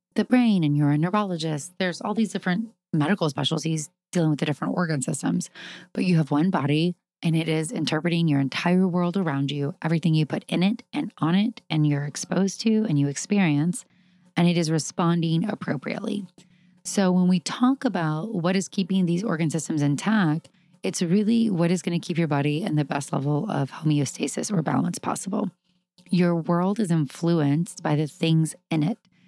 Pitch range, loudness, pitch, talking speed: 155-190 Hz, -24 LUFS, 175 Hz, 185 wpm